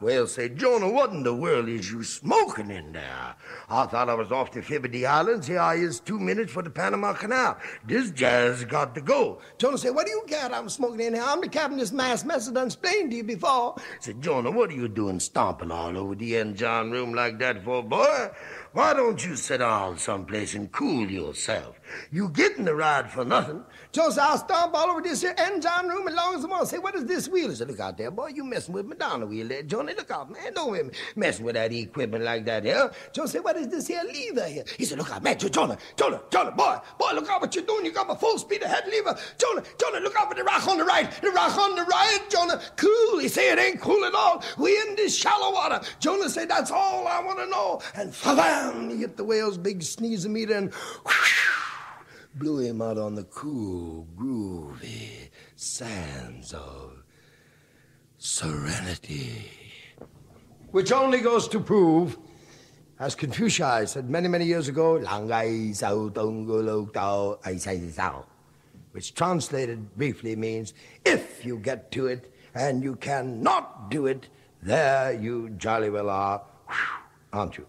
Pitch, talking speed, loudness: 155 Hz, 200 wpm, -26 LUFS